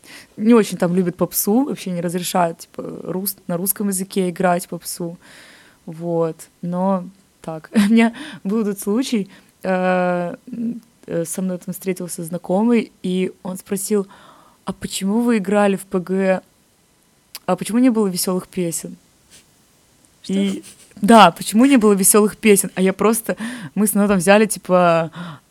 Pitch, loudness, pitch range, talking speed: 190 Hz, -18 LUFS, 180-210 Hz, 135 wpm